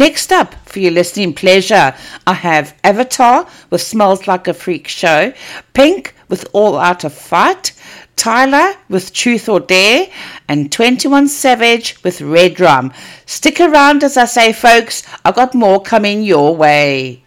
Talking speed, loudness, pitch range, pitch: 155 wpm, -11 LUFS, 175-260 Hz, 210 Hz